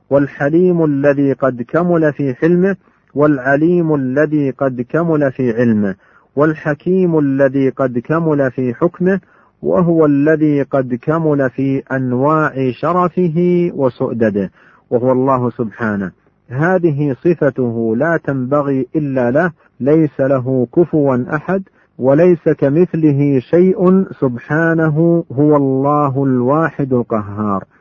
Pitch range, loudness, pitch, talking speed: 130-165 Hz, -14 LUFS, 145 Hz, 100 wpm